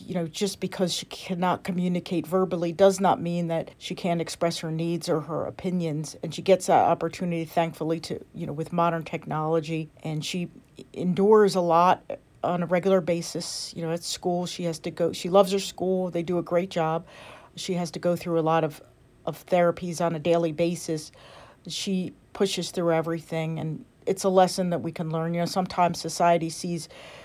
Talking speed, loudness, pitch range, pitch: 195 wpm, -26 LUFS, 165-180 Hz, 170 Hz